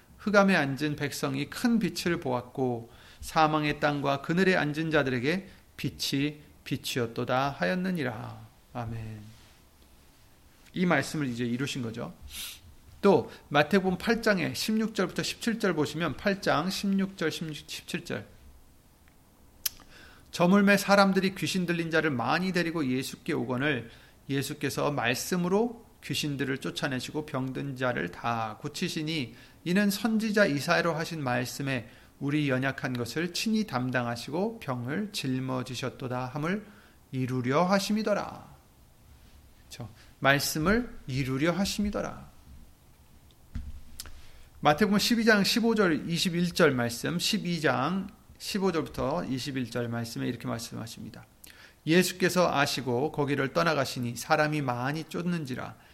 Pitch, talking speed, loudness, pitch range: 150 Hz, 245 characters per minute, -28 LUFS, 125-180 Hz